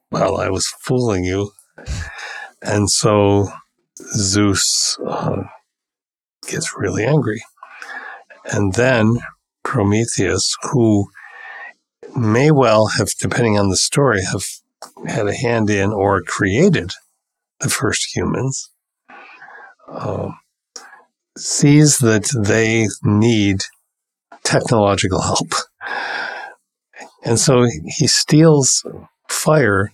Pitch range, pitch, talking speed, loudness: 100-120 Hz, 110 Hz, 90 wpm, -16 LUFS